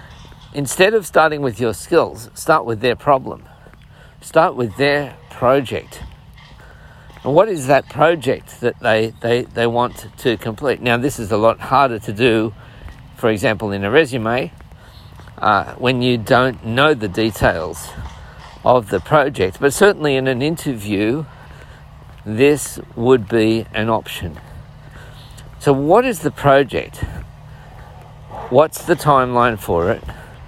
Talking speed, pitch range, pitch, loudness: 135 wpm, 115-140 Hz, 125 Hz, -17 LUFS